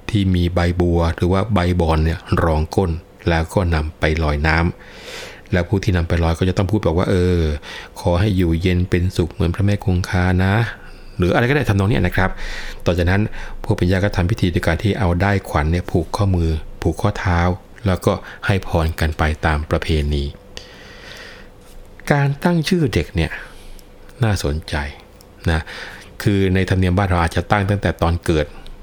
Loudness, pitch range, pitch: -19 LUFS, 85-100 Hz, 90 Hz